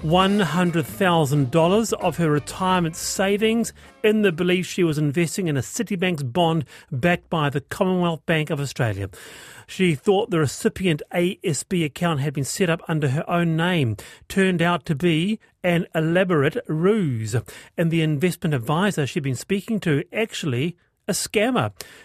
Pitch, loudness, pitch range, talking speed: 170 Hz, -22 LUFS, 150-185 Hz, 145 wpm